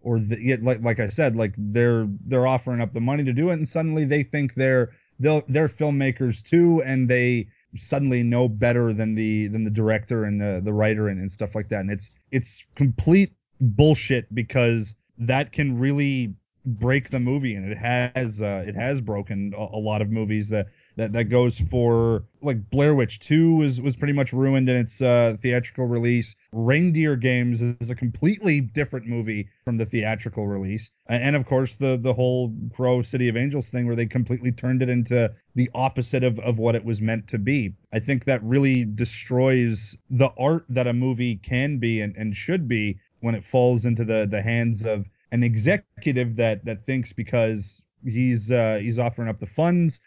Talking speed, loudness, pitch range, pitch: 195 wpm, -23 LUFS, 110-130 Hz, 120 Hz